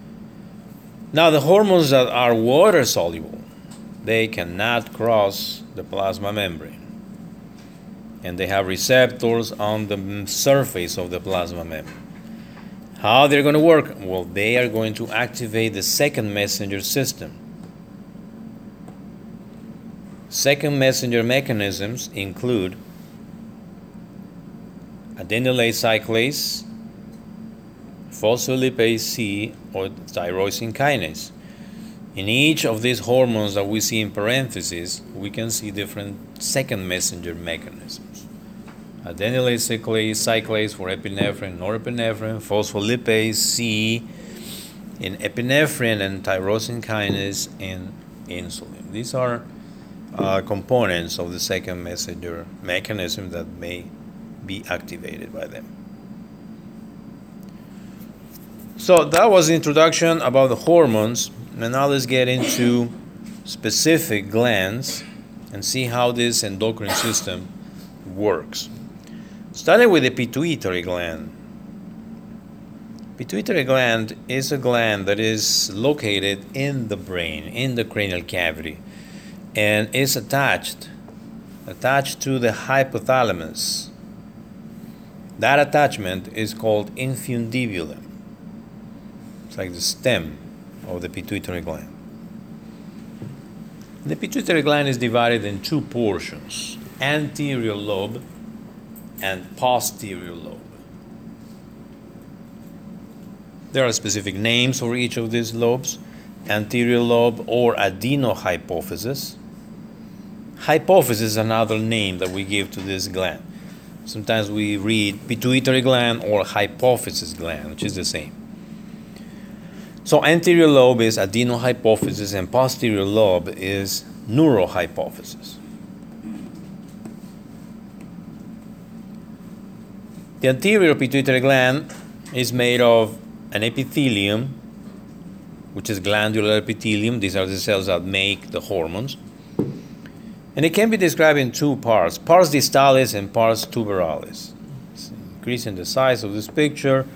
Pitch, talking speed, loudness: 125 Hz, 105 wpm, -20 LUFS